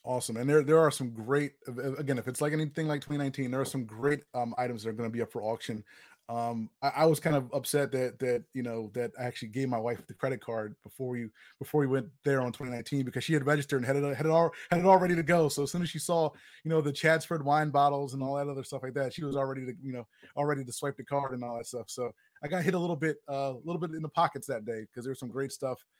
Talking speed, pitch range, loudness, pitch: 295 wpm, 125-150 Hz, -31 LUFS, 135 Hz